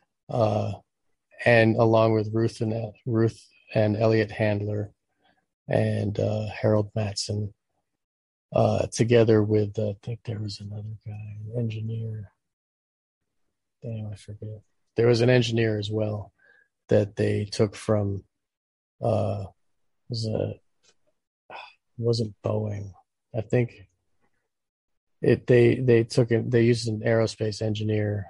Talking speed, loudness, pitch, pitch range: 120 wpm, -25 LUFS, 110 Hz, 105-115 Hz